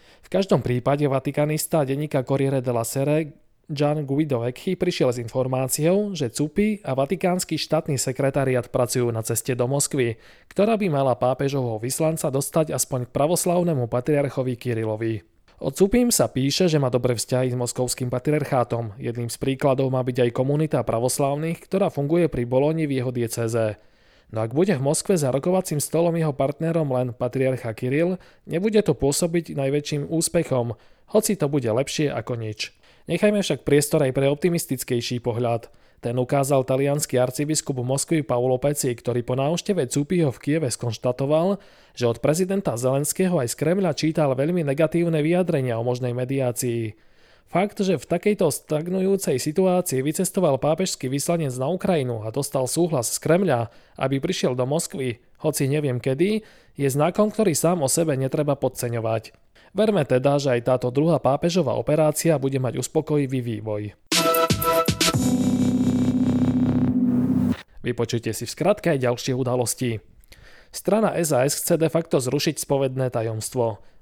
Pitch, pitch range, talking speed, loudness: 140 Hz, 125-165 Hz, 145 wpm, -23 LUFS